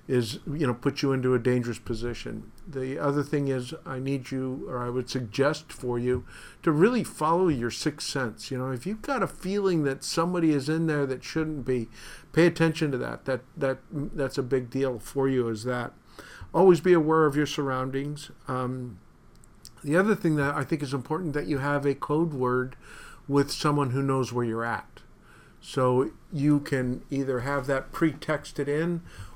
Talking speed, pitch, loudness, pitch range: 190 wpm, 140 Hz, -27 LUFS, 125-155 Hz